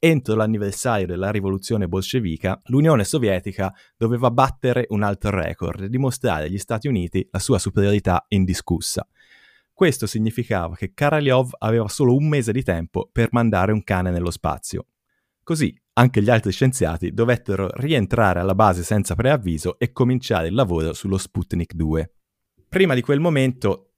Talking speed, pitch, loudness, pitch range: 150 wpm, 105 Hz, -21 LUFS, 95-125 Hz